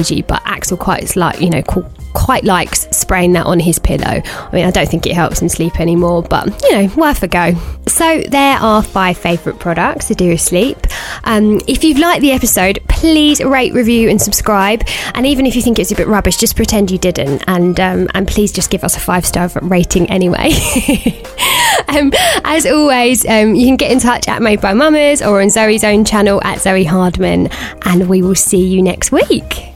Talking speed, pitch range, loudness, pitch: 205 wpm, 180-245 Hz, -11 LUFS, 200 Hz